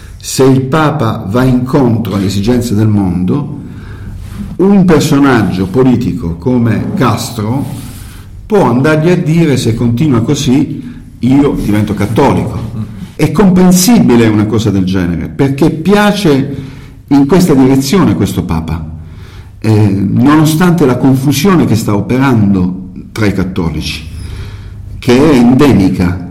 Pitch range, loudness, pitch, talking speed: 100-140 Hz, -9 LUFS, 115 Hz, 115 wpm